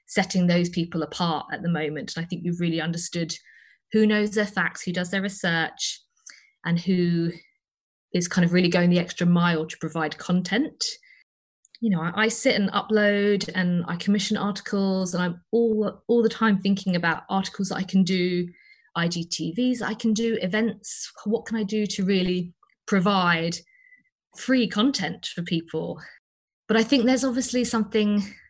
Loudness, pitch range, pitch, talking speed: -24 LUFS, 175-220 Hz, 195 Hz, 170 wpm